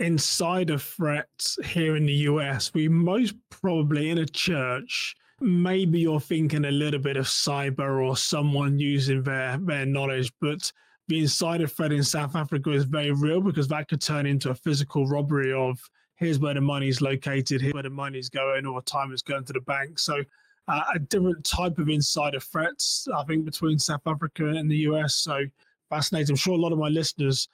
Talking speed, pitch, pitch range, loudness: 195 wpm, 150 Hz, 140-160 Hz, -26 LUFS